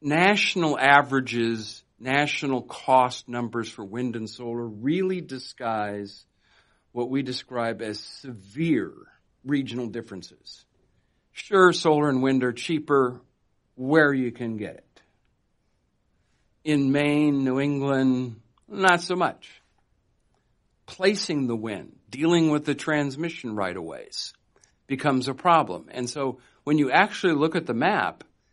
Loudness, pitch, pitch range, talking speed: -24 LUFS, 130 Hz, 115-150 Hz, 120 wpm